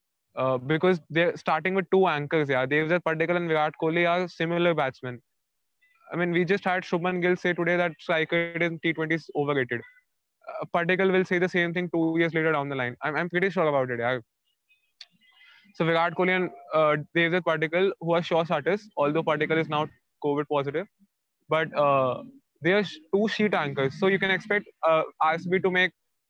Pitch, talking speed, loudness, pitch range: 170 Hz, 190 wpm, -25 LUFS, 155-185 Hz